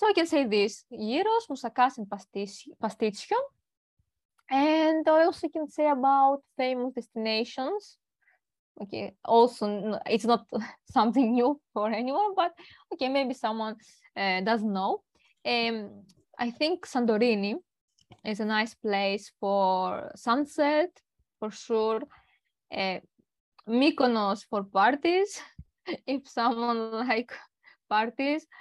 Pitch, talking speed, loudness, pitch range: 240 Hz, 110 wpm, -28 LUFS, 215-300 Hz